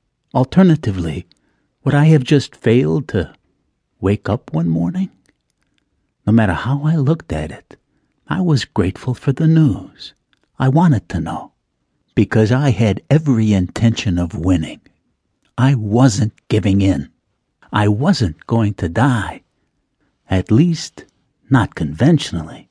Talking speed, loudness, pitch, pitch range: 125 wpm, -16 LUFS, 115 Hz, 100-140 Hz